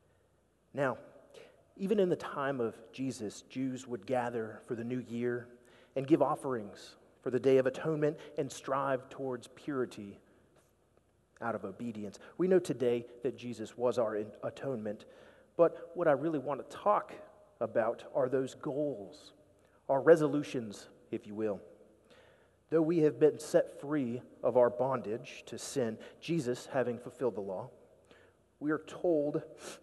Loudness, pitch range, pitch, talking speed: -34 LUFS, 120-150 Hz, 130 Hz, 145 wpm